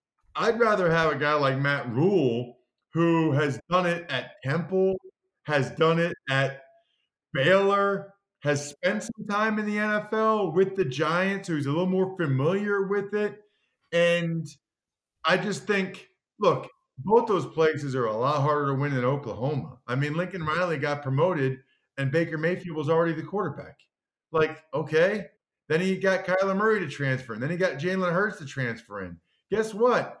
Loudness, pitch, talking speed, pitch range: -26 LUFS, 170 Hz, 170 wpm, 145-195 Hz